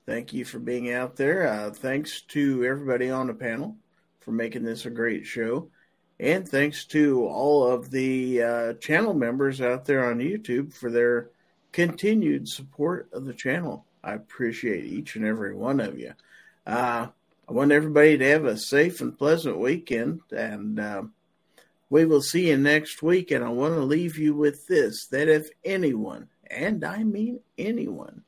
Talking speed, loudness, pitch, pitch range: 170 wpm, -25 LUFS, 140 Hz, 125-155 Hz